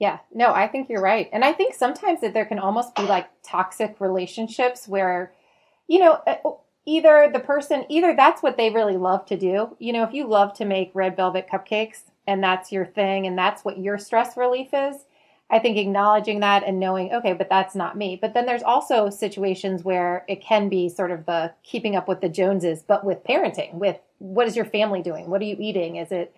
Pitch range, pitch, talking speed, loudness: 190-240 Hz, 205 Hz, 220 wpm, -22 LUFS